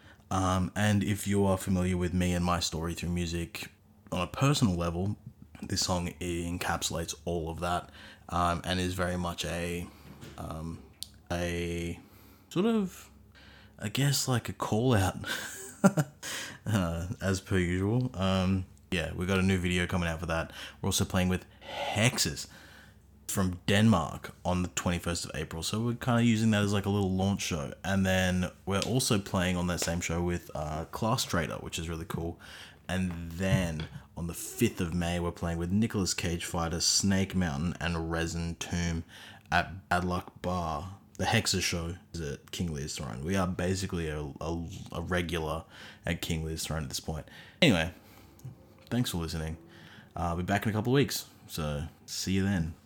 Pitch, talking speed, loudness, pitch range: 90 Hz, 180 wpm, -31 LUFS, 85-100 Hz